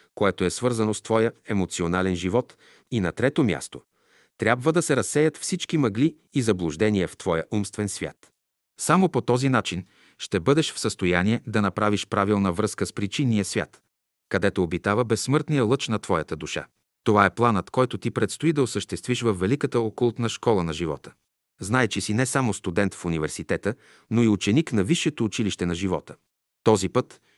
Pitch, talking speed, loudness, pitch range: 110 Hz, 170 wpm, -24 LUFS, 100-125 Hz